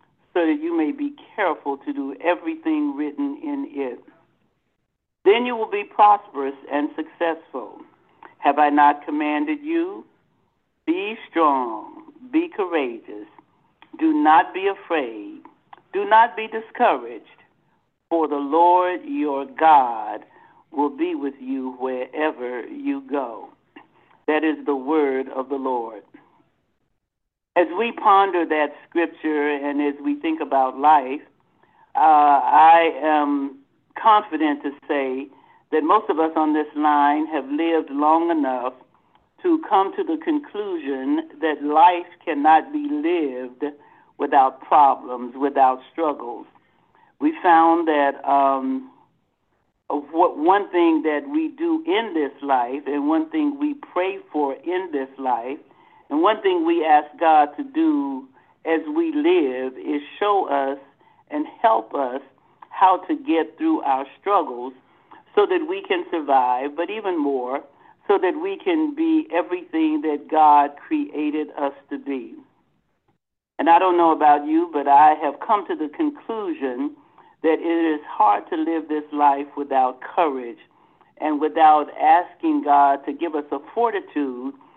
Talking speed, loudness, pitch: 135 wpm, -21 LUFS, 160 Hz